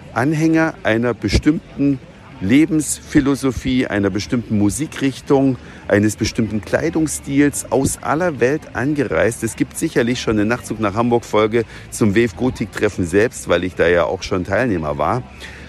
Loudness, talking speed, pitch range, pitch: -18 LUFS, 140 wpm, 110-140 Hz, 120 Hz